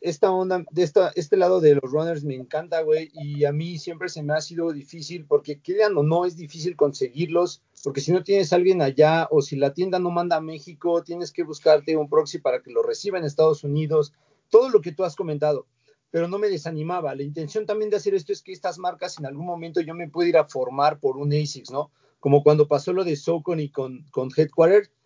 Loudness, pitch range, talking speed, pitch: -23 LUFS, 150-180 Hz, 235 wpm, 165 Hz